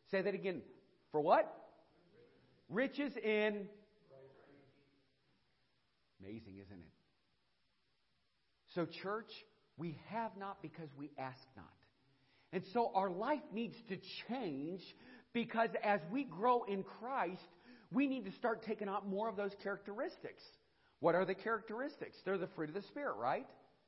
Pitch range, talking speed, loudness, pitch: 160-230 Hz, 135 wpm, -40 LUFS, 200 Hz